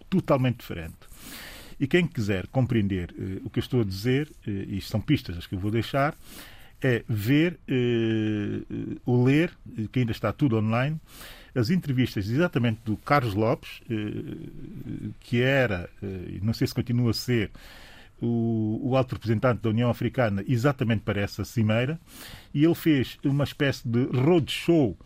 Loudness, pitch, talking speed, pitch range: -26 LUFS, 120 Hz, 160 wpm, 110-140 Hz